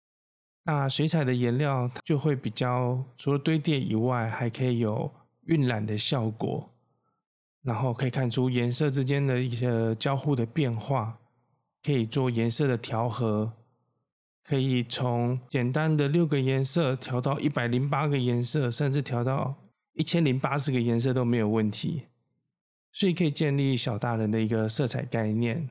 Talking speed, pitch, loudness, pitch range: 240 characters per minute, 130 Hz, -27 LUFS, 120-140 Hz